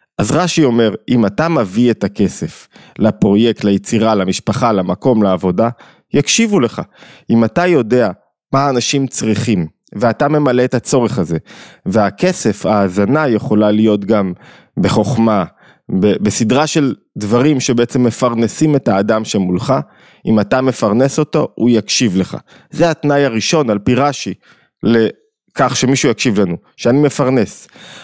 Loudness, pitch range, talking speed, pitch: -14 LUFS, 105-135 Hz, 130 wpm, 115 Hz